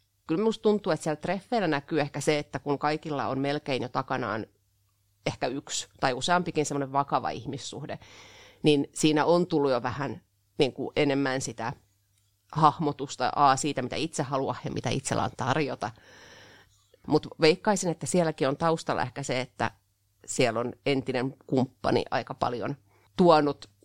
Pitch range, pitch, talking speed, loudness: 115-155 Hz, 140 Hz, 150 wpm, -28 LUFS